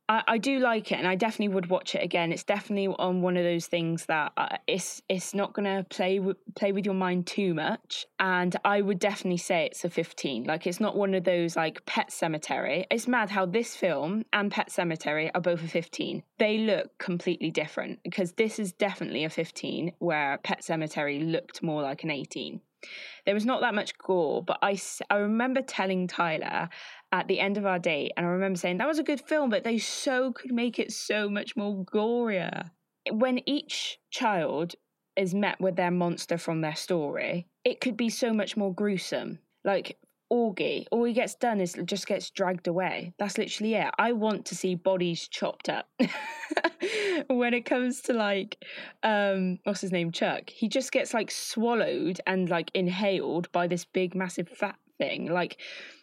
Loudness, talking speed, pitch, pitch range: -29 LUFS, 195 wpm, 195 Hz, 180-225 Hz